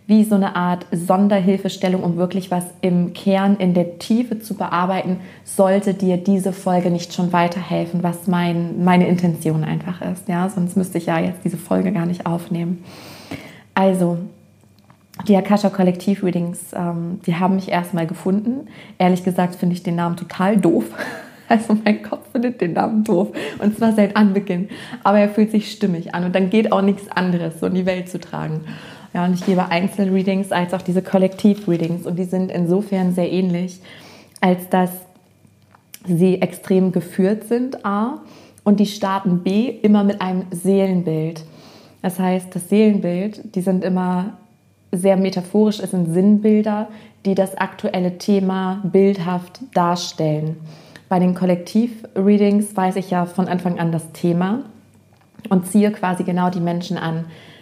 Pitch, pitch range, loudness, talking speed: 185 Hz, 175-200 Hz, -19 LUFS, 155 wpm